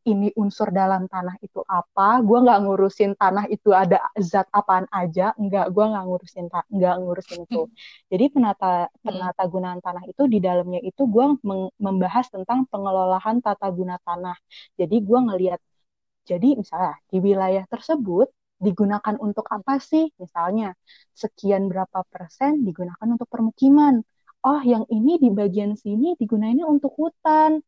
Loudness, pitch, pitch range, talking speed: -21 LUFS, 205 Hz, 185-235 Hz, 145 wpm